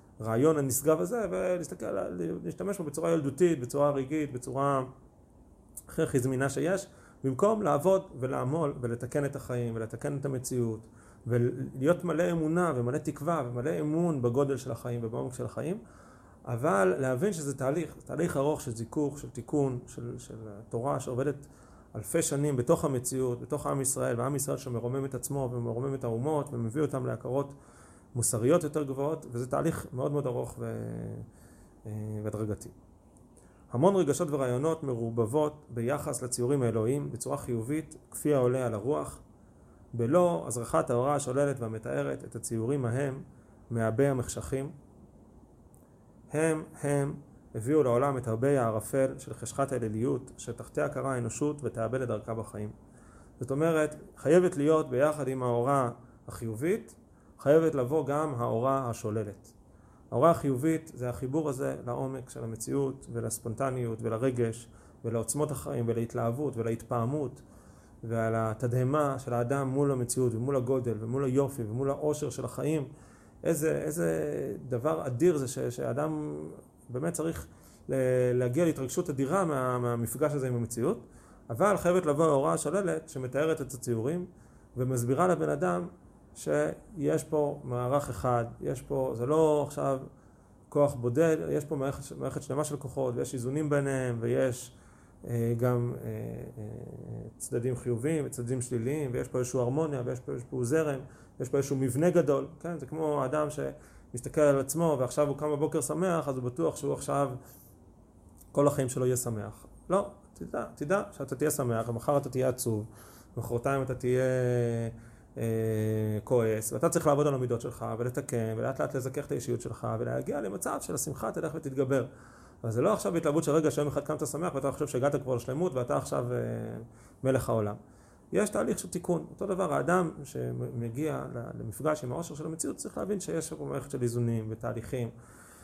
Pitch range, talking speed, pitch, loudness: 115-150 Hz, 145 wpm, 130 Hz, -31 LUFS